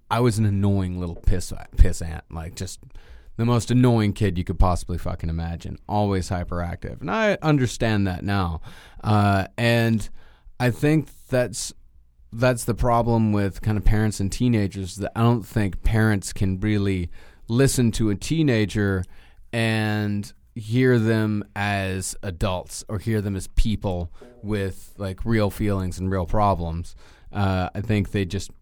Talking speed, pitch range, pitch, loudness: 155 wpm, 95-115 Hz, 100 Hz, -23 LUFS